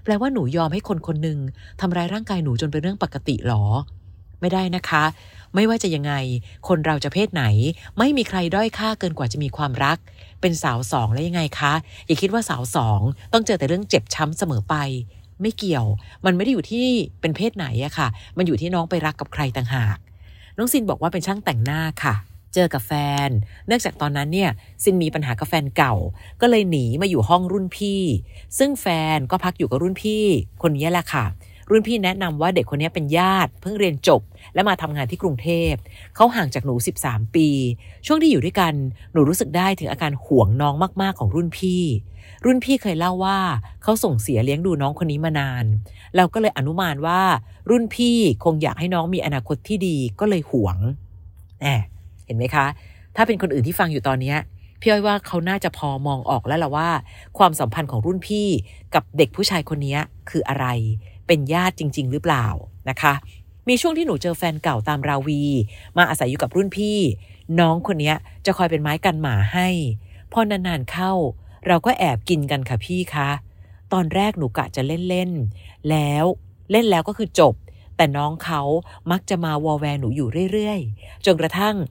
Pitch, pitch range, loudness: 155 Hz, 125-185 Hz, -21 LUFS